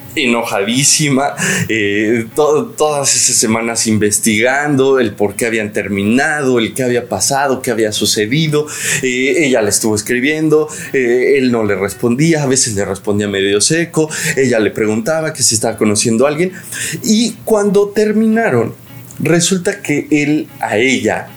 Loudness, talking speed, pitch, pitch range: -13 LUFS, 145 wpm, 130 Hz, 110-160 Hz